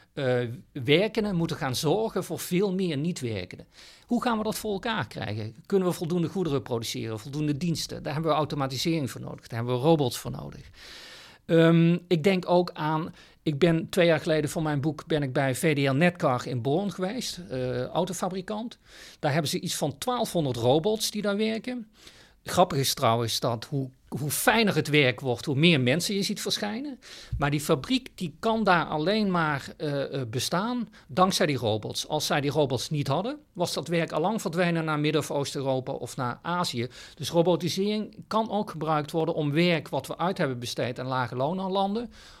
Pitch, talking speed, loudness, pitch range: 160 Hz, 190 wpm, -27 LUFS, 140-185 Hz